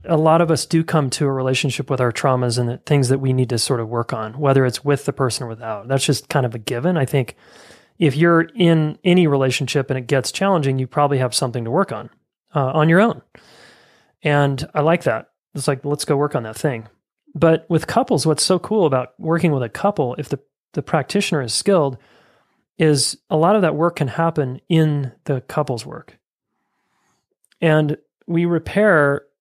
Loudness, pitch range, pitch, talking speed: -19 LUFS, 130-165 Hz, 145 Hz, 210 wpm